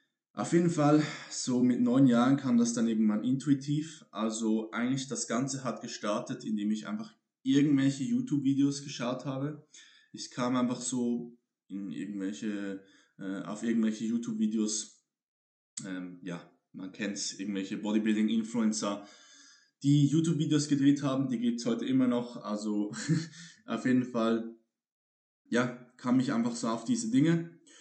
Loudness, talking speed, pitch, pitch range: -30 LUFS, 140 wpm, 125 Hz, 110-145 Hz